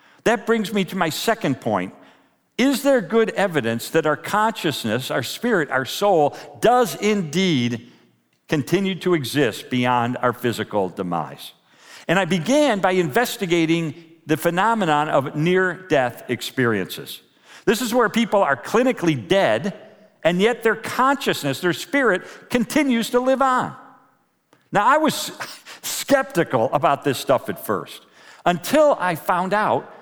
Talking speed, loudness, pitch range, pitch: 135 wpm, -20 LUFS, 140-225 Hz, 180 Hz